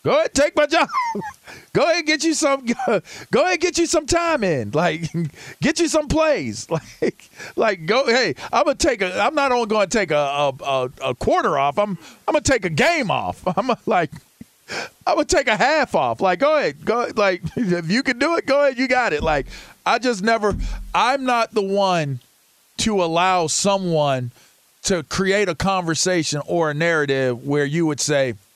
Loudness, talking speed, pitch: -20 LUFS, 195 wpm, 200 Hz